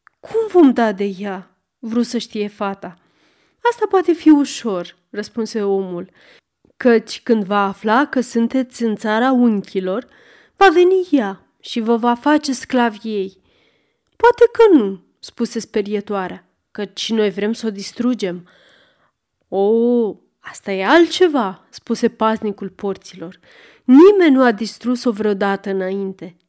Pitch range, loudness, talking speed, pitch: 195-255 Hz, -17 LUFS, 130 wpm, 225 Hz